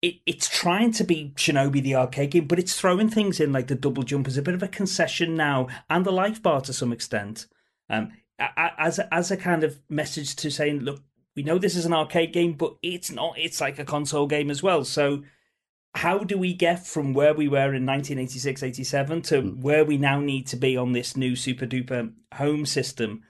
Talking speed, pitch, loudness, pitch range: 220 wpm, 145 Hz, -24 LUFS, 135-170 Hz